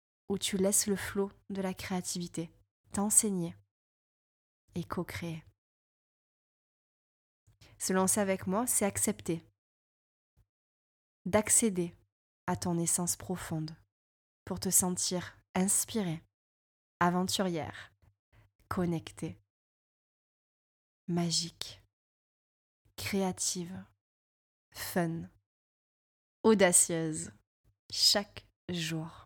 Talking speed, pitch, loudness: 70 wpm, 170 Hz, -31 LUFS